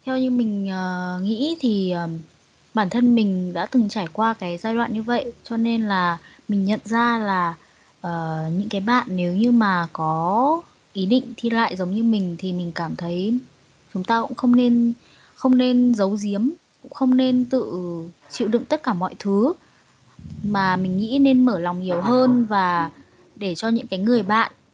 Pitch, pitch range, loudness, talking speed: 215 Hz, 185-240 Hz, -21 LUFS, 190 wpm